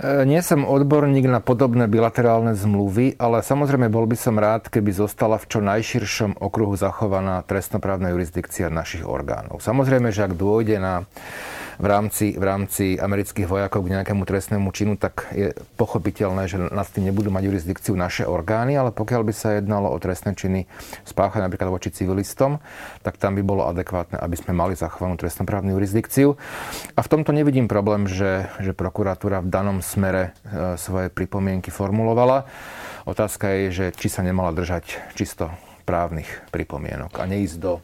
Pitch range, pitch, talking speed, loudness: 95-115 Hz, 100 Hz, 160 wpm, -22 LUFS